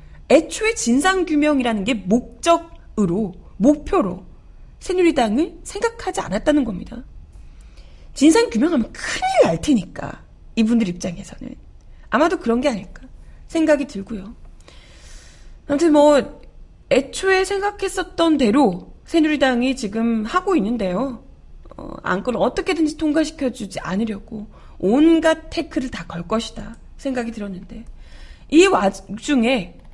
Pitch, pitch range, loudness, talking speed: 260 Hz, 220-320 Hz, -19 LUFS, 275 characters per minute